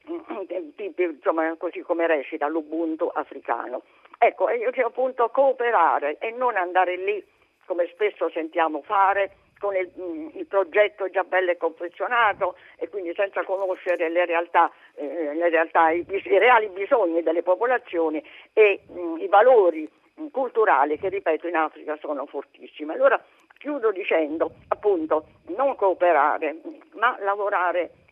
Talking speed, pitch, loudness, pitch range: 130 wpm, 190 Hz, -23 LUFS, 170-265 Hz